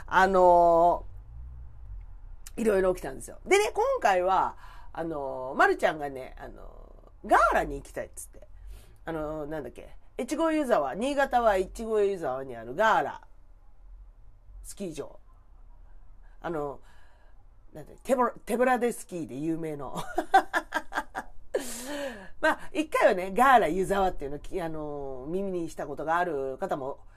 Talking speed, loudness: 275 characters per minute, -27 LUFS